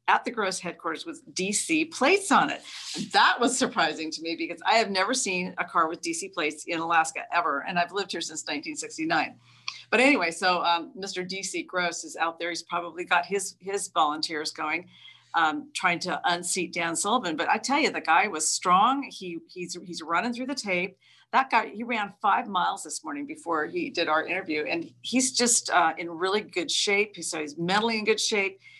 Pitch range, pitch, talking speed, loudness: 170-230 Hz, 185 Hz, 205 wpm, -26 LUFS